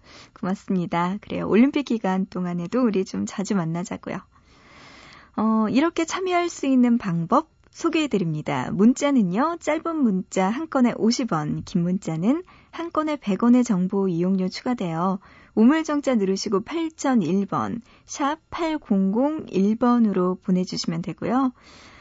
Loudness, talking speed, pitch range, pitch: -23 LUFS, 265 characters per minute, 190-280 Hz, 220 Hz